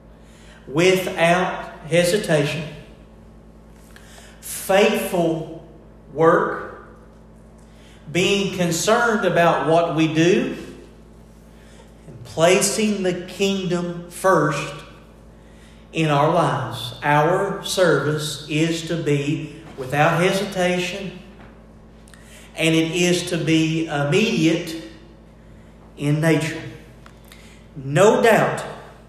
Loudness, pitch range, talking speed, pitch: -19 LUFS, 155-185 Hz, 70 wpm, 170 Hz